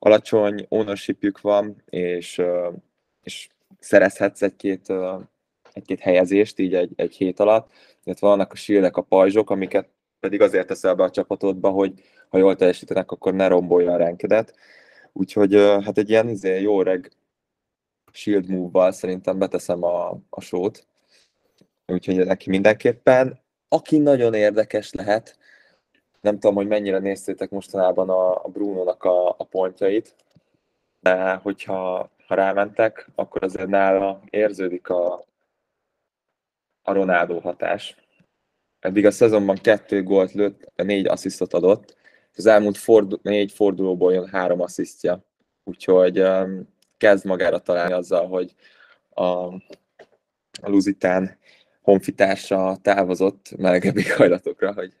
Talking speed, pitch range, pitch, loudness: 120 wpm, 90-100 Hz, 95 Hz, -20 LUFS